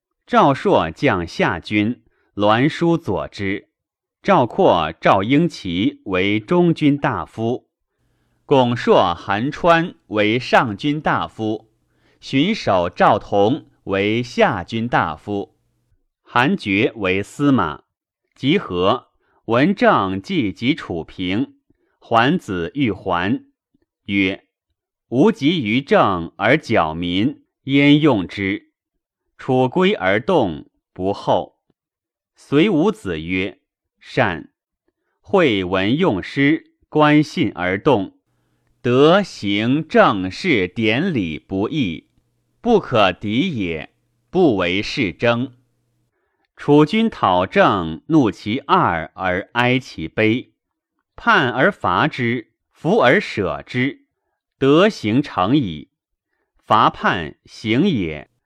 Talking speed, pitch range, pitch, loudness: 130 characters per minute, 100-155 Hz, 120 Hz, -18 LUFS